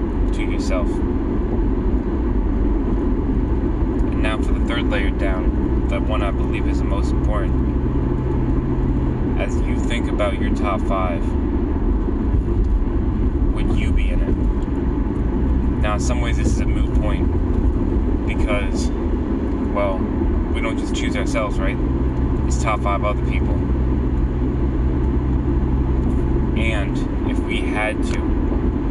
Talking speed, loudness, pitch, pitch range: 115 wpm, -21 LUFS, 65 Hz, 65-70 Hz